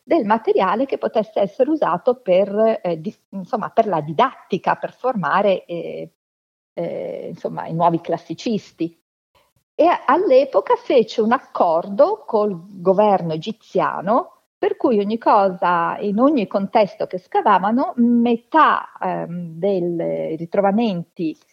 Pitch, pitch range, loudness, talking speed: 205 Hz, 175-250 Hz, -19 LUFS, 120 wpm